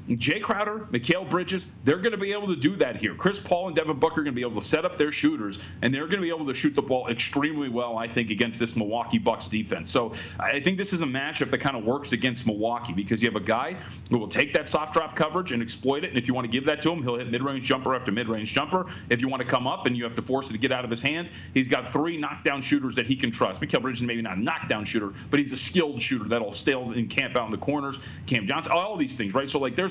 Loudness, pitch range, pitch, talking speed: -26 LUFS, 120-155 Hz, 130 Hz, 305 wpm